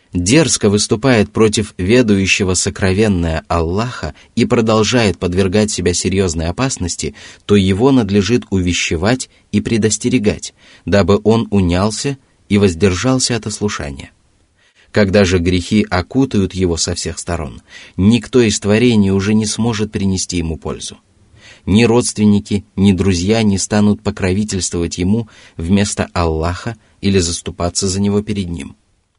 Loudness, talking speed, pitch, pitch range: -15 LUFS, 120 wpm, 100 Hz, 90-110 Hz